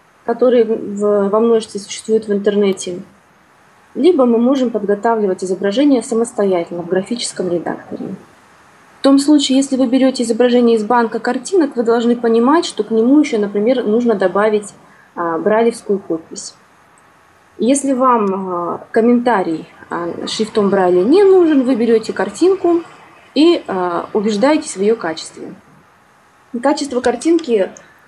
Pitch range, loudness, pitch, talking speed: 200-260 Hz, -15 LUFS, 230 Hz, 125 wpm